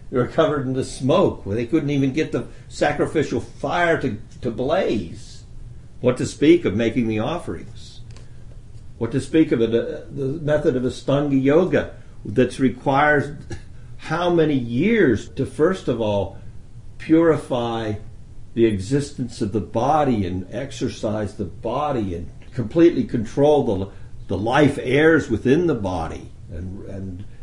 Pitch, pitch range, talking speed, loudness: 120 Hz, 110-145 Hz, 140 wpm, -21 LUFS